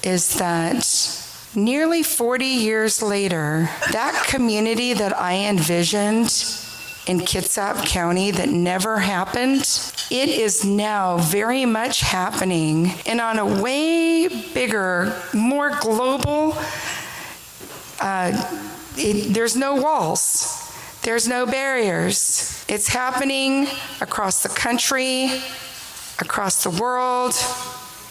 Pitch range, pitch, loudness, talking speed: 190-260 Hz, 230 Hz, -20 LUFS, 100 wpm